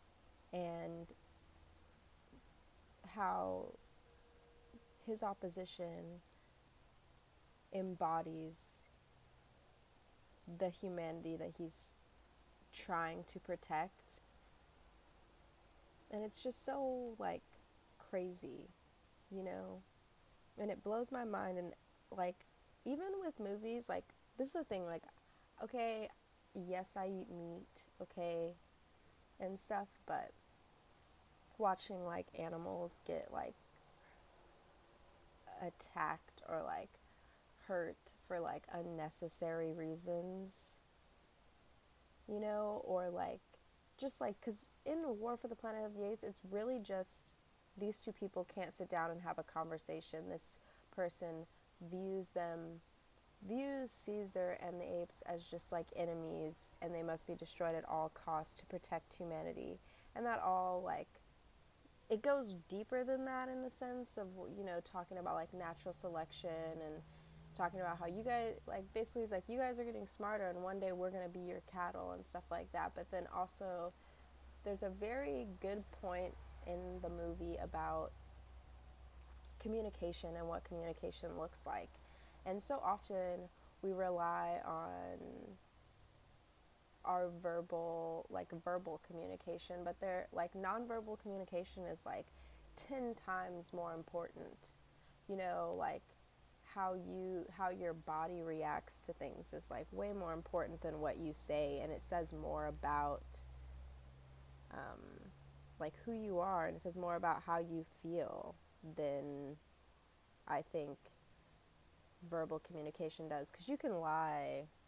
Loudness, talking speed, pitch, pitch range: -45 LUFS, 130 wpm, 175 Hz, 150-190 Hz